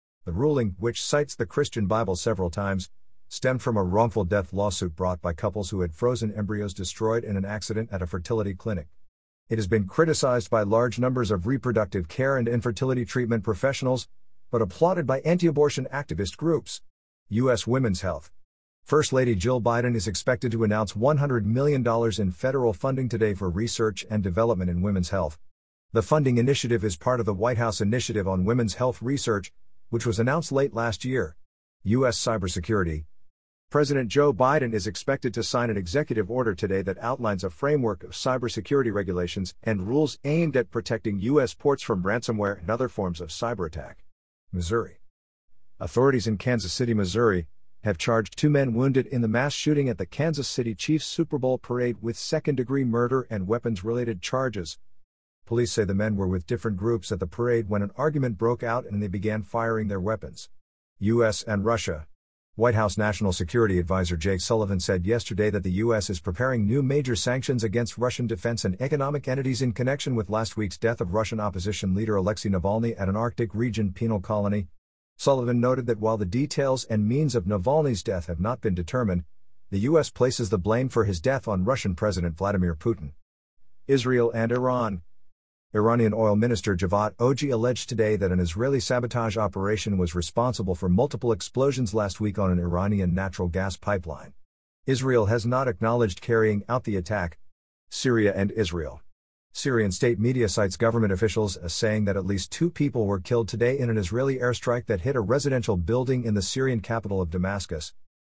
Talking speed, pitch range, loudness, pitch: 180 wpm, 95-125 Hz, -26 LUFS, 110 Hz